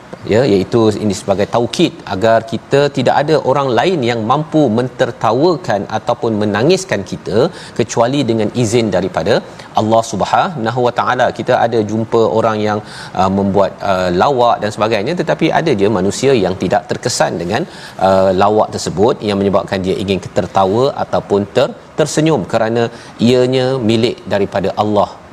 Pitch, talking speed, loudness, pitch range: 115 Hz, 140 wpm, -14 LUFS, 100-125 Hz